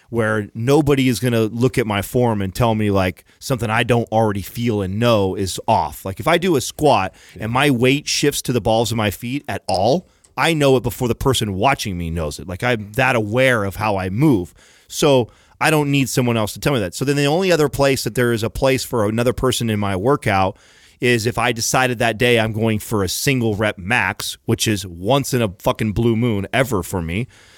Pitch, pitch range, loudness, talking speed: 115 Hz, 105-130 Hz, -18 LUFS, 235 wpm